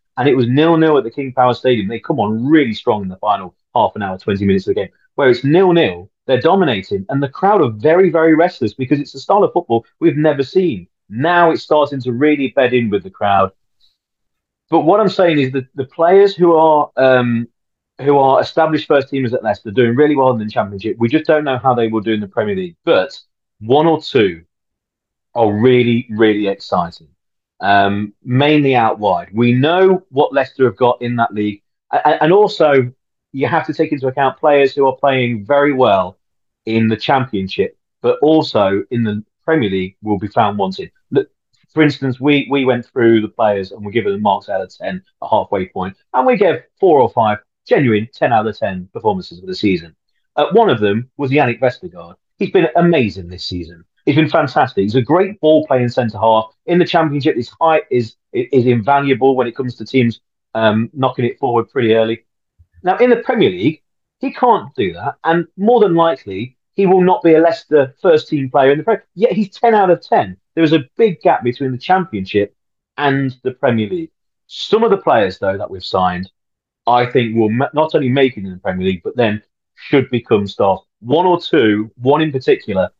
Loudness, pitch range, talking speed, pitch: -15 LUFS, 110-160 Hz, 210 wpm, 130 Hz